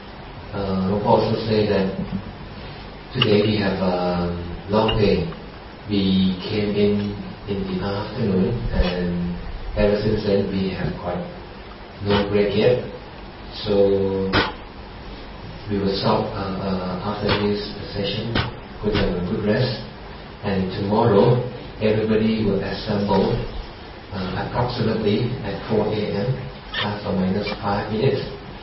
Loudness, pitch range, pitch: -22 LUFS, 95-105 Hz, 100 Hz